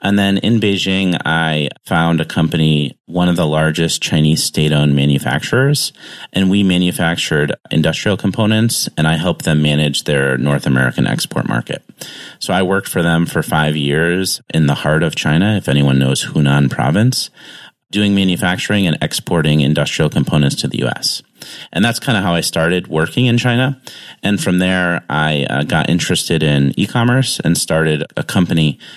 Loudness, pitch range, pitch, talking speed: -15 LUFS, 75-100 Hz, 85 Hz, 165 wpm